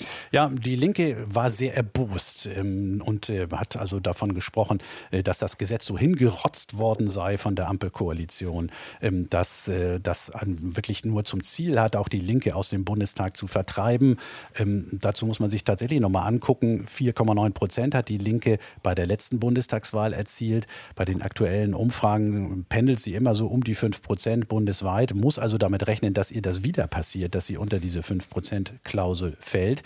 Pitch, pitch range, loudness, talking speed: 105 Hz, 95-115 Hz, -26 LUFS, 175 wpm